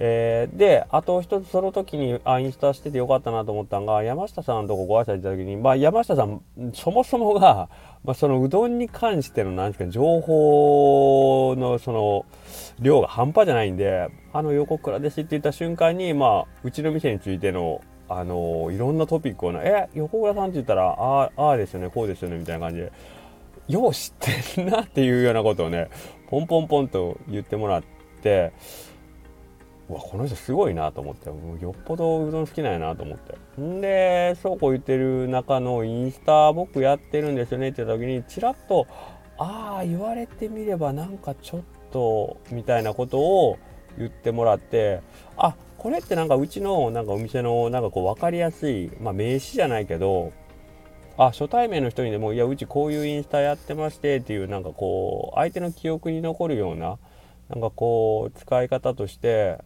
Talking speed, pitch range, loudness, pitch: 380 characters per minute, 110-160 Hz, -23 LUFS, 135 Hz